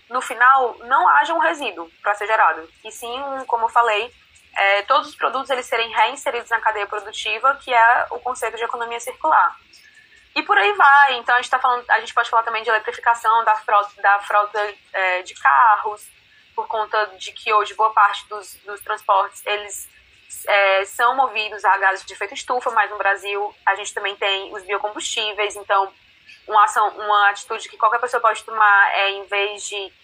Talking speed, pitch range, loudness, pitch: 190 wpm, 205-245 Hz, -18 LUFS, 220 Hz